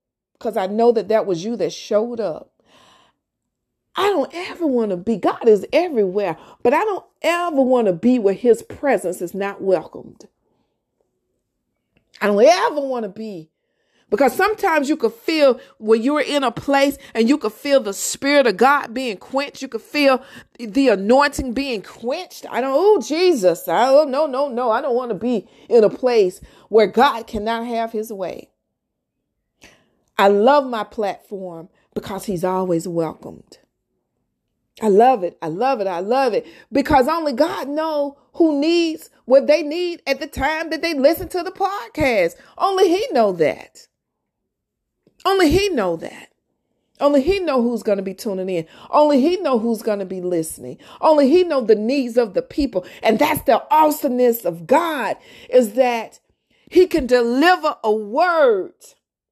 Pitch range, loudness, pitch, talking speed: 220-310 Hz, -18 LUFS, 265 Hz, 170 wpm